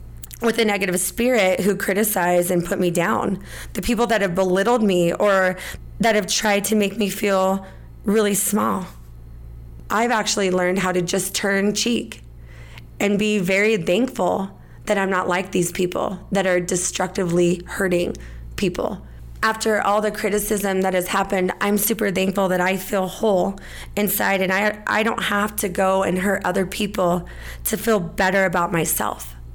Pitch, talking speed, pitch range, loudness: 195 Hz, 160 wpm, 180-210 Hz, -20 LUFS